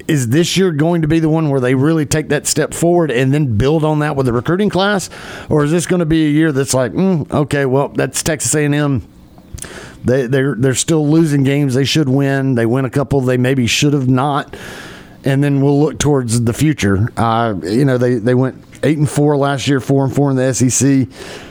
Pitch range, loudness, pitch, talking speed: 130-155 Hz, -14 LUFS, 140 Hz, 230 wpm